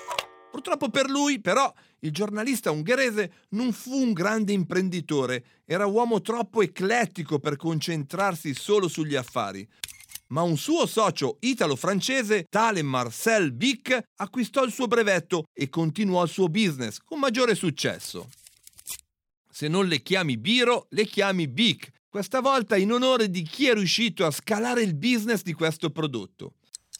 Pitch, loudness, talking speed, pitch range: 200 Hz, -25 LUFS, 145 wpm, 165-235 Hz